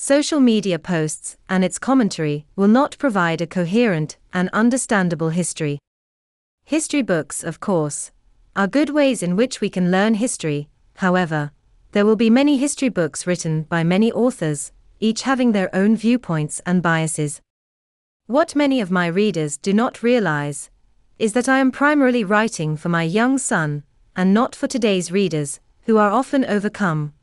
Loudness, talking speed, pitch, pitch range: -19 LUFS, 160 wpm, 185 Hz, 155-240 Hz